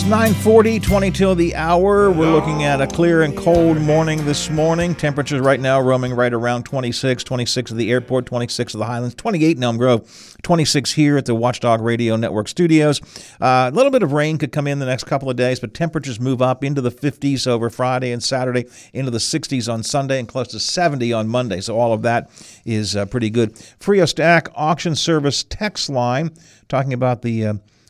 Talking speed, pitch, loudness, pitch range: 205 wpm, 130 Hz, -18 LUFS, 120-155 Hz